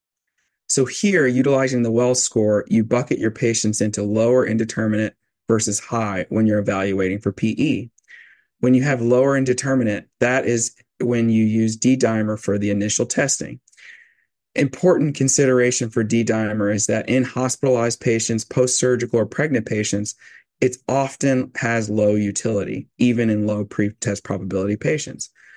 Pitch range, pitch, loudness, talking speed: 105-125 Hz, 115 Hz, -20 LUFS, 145 wpm